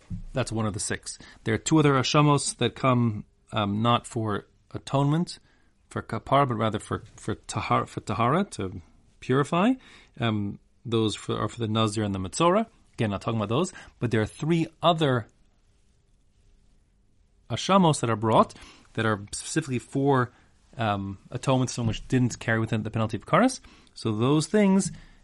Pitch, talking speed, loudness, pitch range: 115 Hz, 165 wpm, -26 LUFS, 105-135 Hz